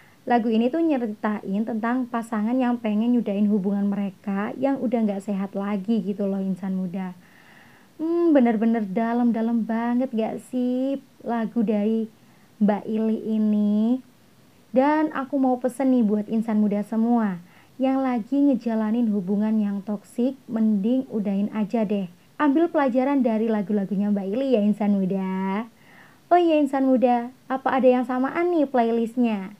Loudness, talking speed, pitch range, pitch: -23 LUFS, 140 wpm, 210-255 Hz, 225 Hz